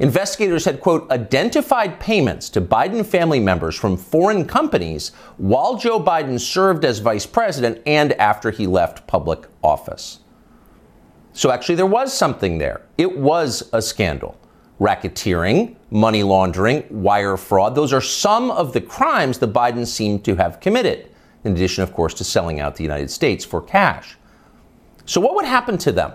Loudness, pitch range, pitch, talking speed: -18 LUFS, 95-150 Hz, 110 Hz, 160 wpm